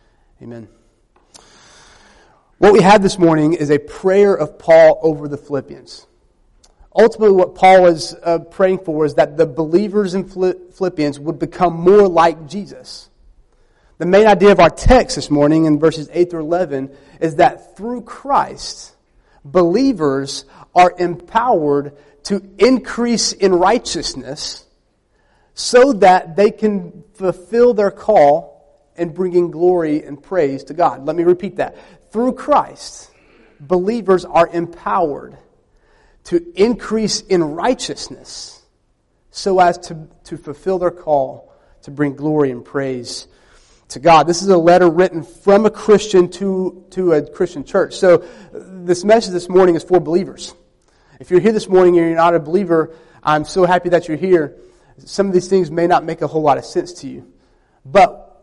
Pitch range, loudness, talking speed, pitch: 150-190 Hz, -15 LUFS, 155 wpm, 175 Hz